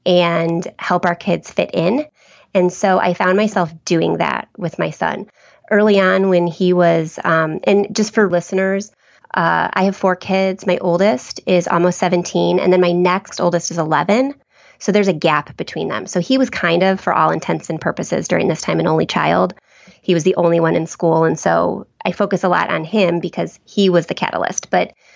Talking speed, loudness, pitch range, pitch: 205 wpm, -16 LUFS, 175-195 Hz, 180 Hz